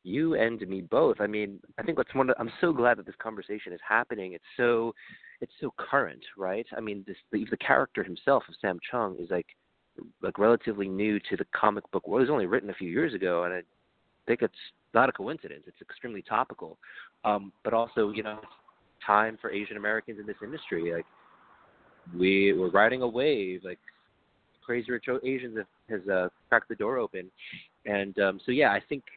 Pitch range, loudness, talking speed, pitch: 100-115 Hz, -29 LUFS, 200 wpm, 105 Hz